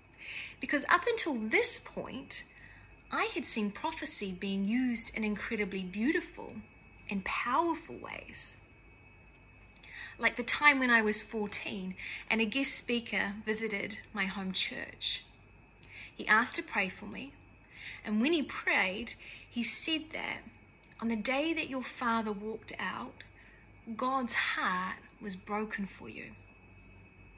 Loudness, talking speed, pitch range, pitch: -32 LUFS, 130 wpm, 205-285 Hz, 225 Hz